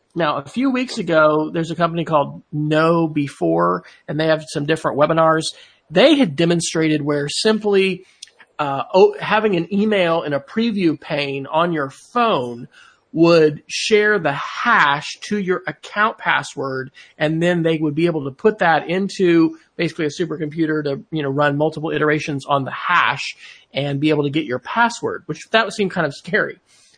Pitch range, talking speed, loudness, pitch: 150-180 Hz, 170 wpm, -18 LUFS, 160 Hz